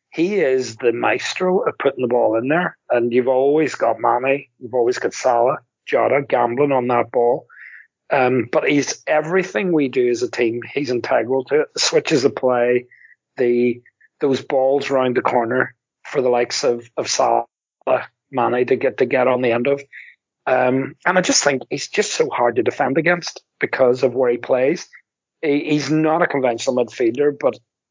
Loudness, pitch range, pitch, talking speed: -19 LUFS, 120-155 Hz, 130 Hz, 185 wpm